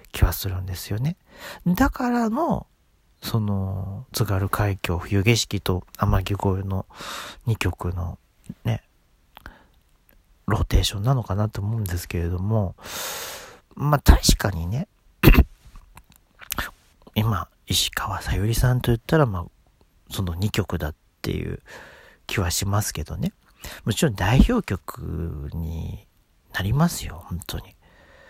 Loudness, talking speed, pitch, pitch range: -24 LUFS, 225 characters per minute, 100 Hz, 85-110 Hz